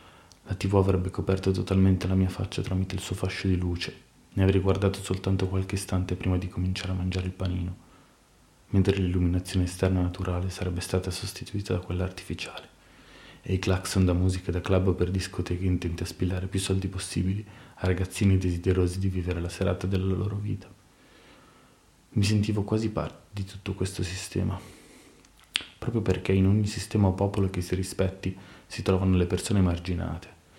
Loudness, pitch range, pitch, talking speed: -28 LUFS, 90-95 Hz, 95 Hz, 165 wpm